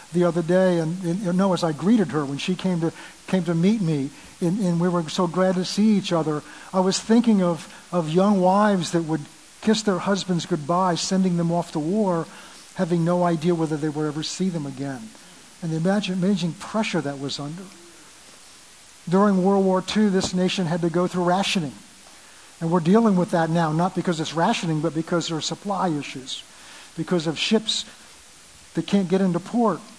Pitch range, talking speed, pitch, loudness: 165-190 Hz, 200 wpm, 180 Hz, -23 LUFS